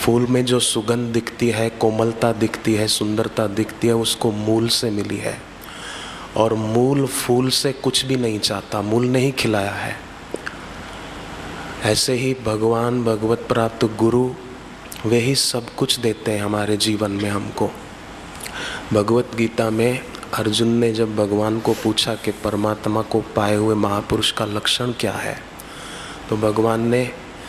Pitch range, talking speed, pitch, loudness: 105-120 Hz, 145 wpm, 115 Hz, -20 LUFS